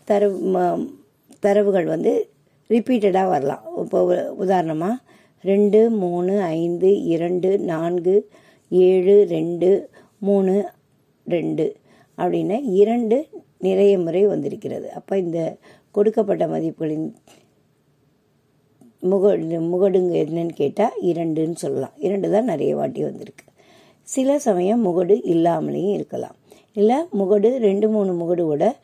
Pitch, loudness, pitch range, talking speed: 195 Hz, -20 LUFS, 175-210 Hz, 95 wpm